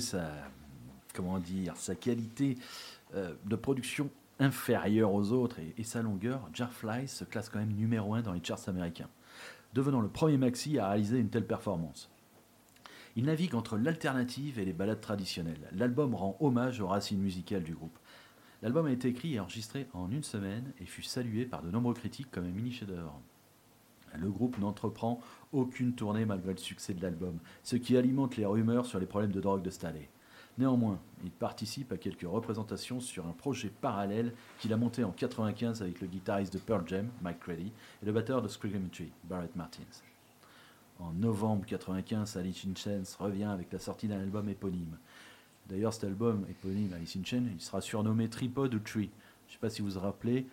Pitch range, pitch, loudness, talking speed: 95-120 Hz, 105 Hz, -35 LUFS, 190 wpm